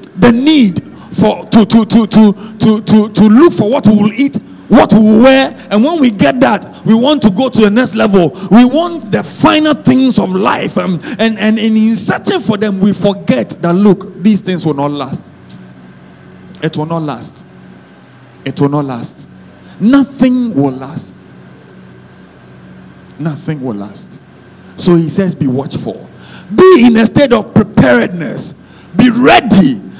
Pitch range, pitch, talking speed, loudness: 145-230 Hz, 205 Hz, 170 wpm, -9 LUFS